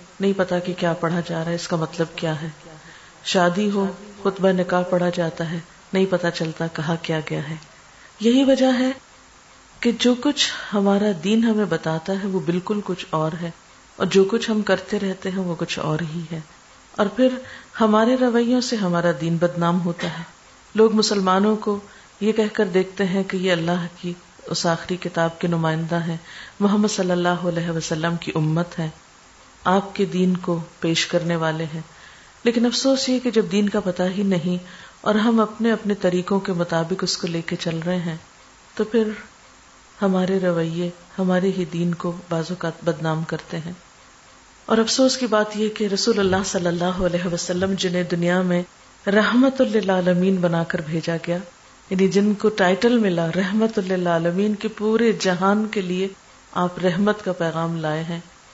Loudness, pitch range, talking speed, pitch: -21 LUFS, 170-210 Hz, 180 wpm, 185 Hz